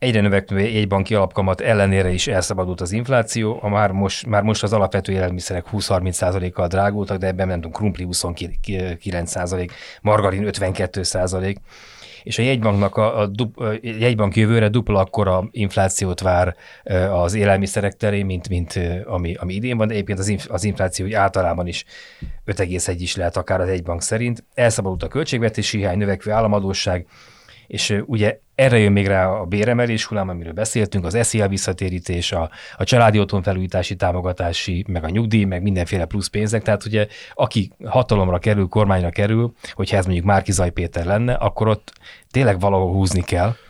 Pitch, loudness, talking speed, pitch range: 100 Hz, -20 LUFS, 155 wpm, 90-105 Hz